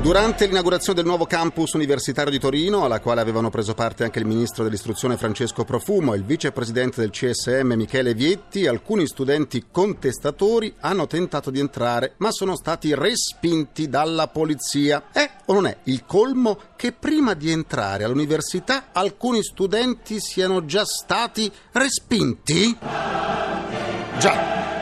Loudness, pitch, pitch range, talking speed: -22 LUFS, 155 Hz, 125-195 Hz, 140 wpm